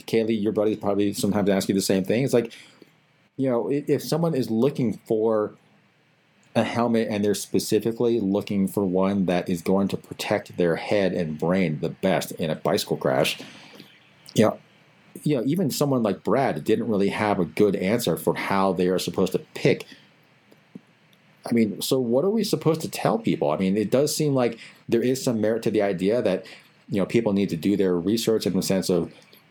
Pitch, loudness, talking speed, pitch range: 105 Hz, -24 LUFS, 200 wpm, 95-120 Hz